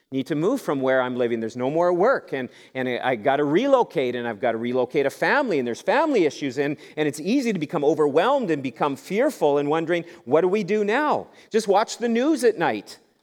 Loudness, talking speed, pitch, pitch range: -23 LUFS, 225 wpm, 150 Hz, 130-200 Hz